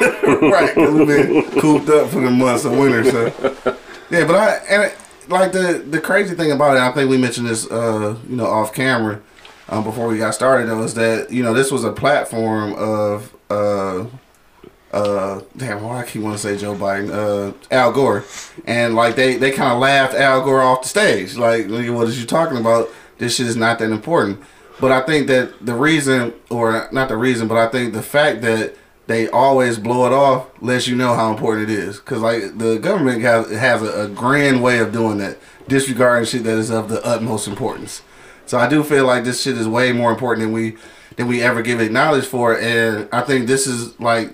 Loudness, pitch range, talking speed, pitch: -16 LUFS, 110-130 Hz, 220 wpm, 120 Hz